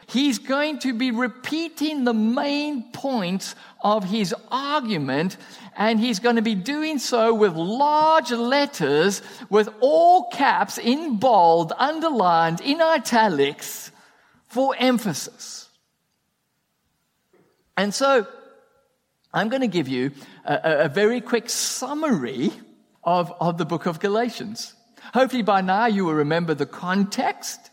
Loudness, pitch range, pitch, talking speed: -22 LUFS, 195-275 Hz, 235 Hz, 125 wpm